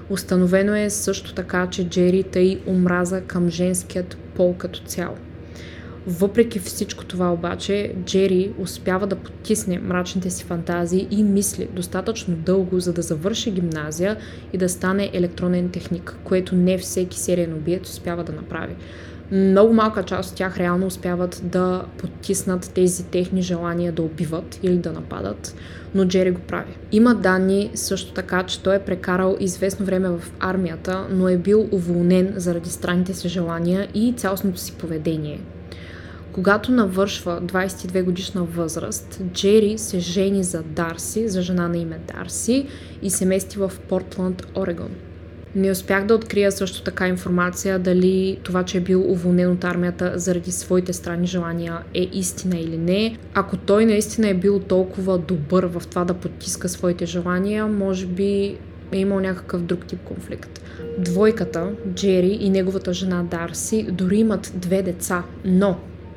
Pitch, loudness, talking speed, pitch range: 185 Hz, -21 LUFS, 150 wpm, 175-195 Hz